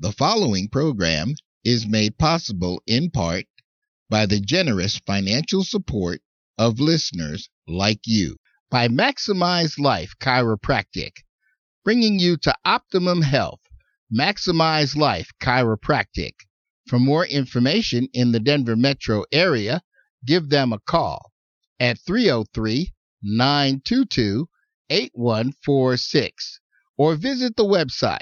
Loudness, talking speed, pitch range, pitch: -21 LUFS, 100 wpm, 110-160 Hz, 130 Hz